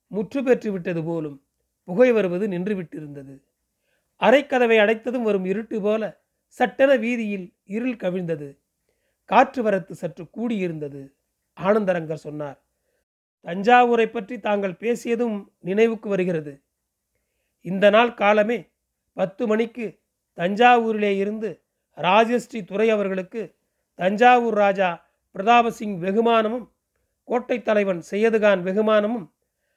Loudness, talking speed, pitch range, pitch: -21 LUFS, 90 wpm, 185-230 Hz, 210 Hz